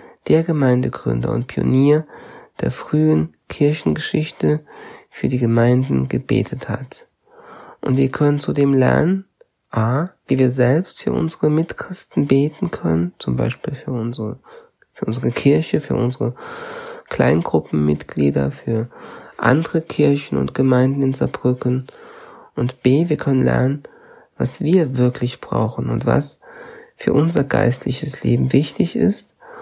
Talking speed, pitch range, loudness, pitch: 120 wpm, 115-160 Hz, -19 LUFS, 130 Hz